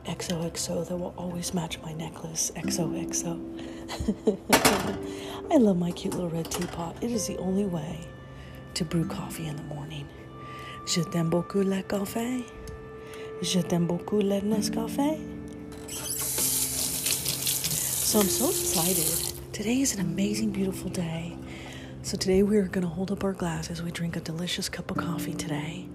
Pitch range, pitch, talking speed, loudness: 150-190 Hz, 170 Hz, 150 wpm, -28 LUFS